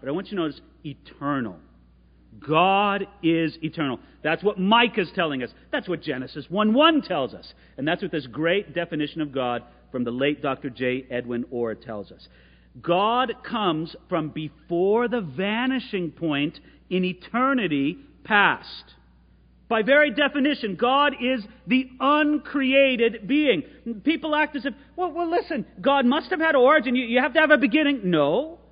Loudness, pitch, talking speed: -23 LUFS, 185 Hz, 160 wpm